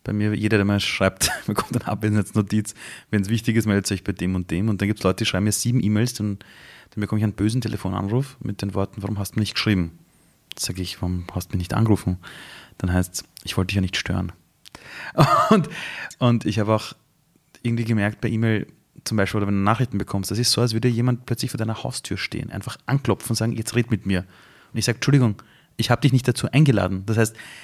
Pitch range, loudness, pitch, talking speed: 100-115 Hz, -23 LUFS, 105 Hz, 240 wpm